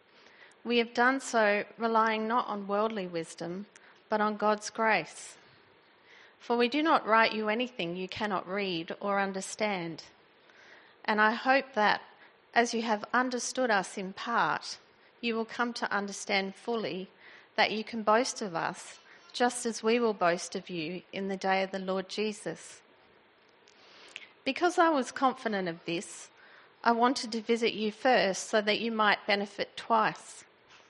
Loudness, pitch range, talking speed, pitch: -30 LUFS, 195-240 Hz, 155 wpm, 215 Hz